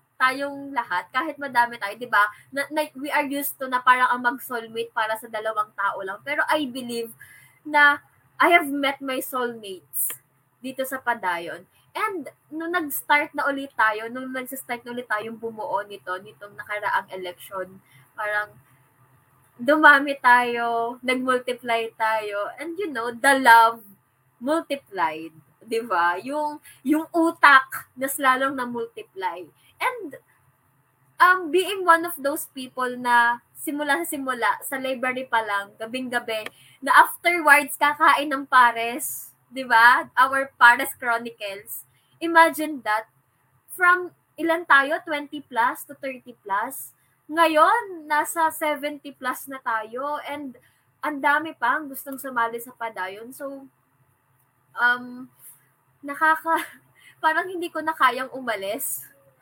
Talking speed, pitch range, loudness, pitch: 130 wpm, 225-295 Hz, -22 LUFS, 255 Hz